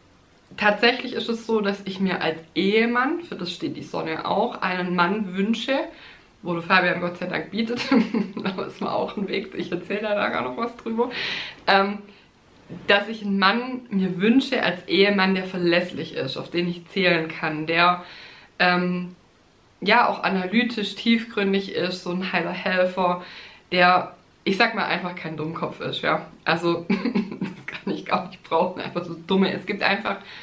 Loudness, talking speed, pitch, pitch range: -23 LUFS, 175 wpm, 190 Hz, 175-215 Hz